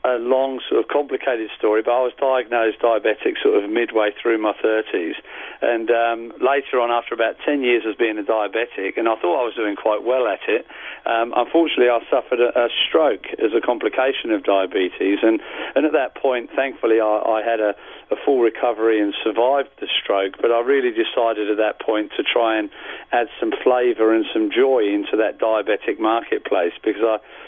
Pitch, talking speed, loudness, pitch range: 115 Hz, 195 wpm, -20 LUFS, 110-135 Hz